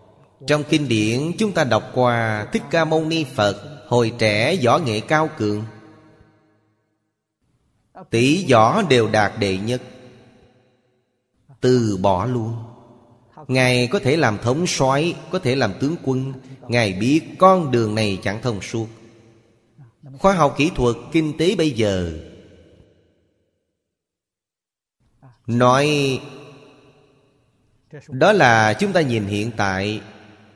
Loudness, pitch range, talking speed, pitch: -19 LUFS, 110-140 Hz, 120 wpm, 125 Hz